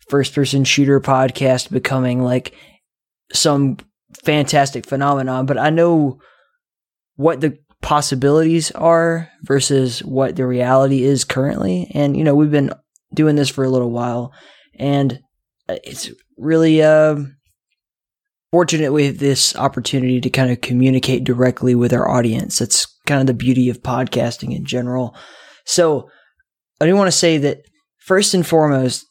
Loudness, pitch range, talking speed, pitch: -16 LUFS, 125-155 Hz, 140 wpm, 140 Hz